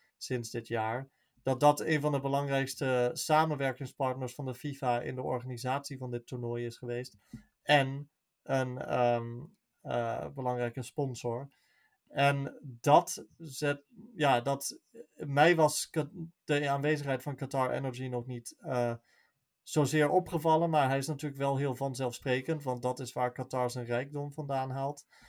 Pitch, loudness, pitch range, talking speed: 135 Hz, -32 LUFS, 125-145 Hz, 140 wpm